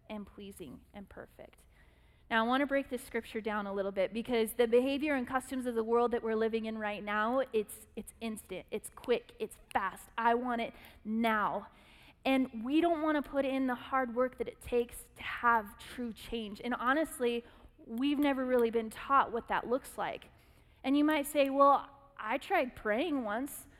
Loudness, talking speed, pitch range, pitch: -33 LUFS, 195 wpm, 225-275 Hz, 240 Hz